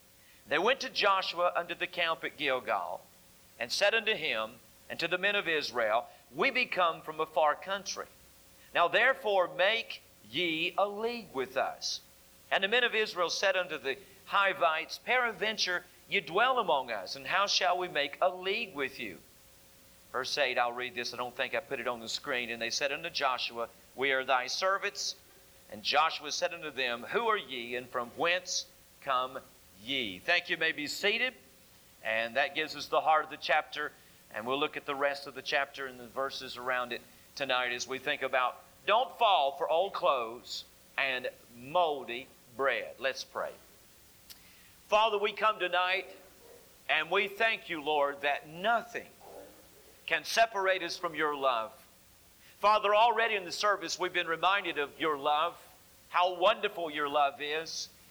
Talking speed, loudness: 175 wpm, -31 LUFS